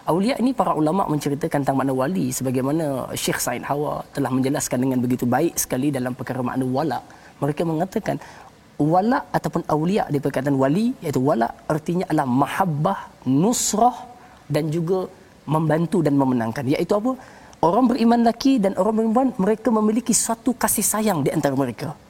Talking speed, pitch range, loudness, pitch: 155 wpm, 140-220 Hz, -21 LUFS, 155 Hz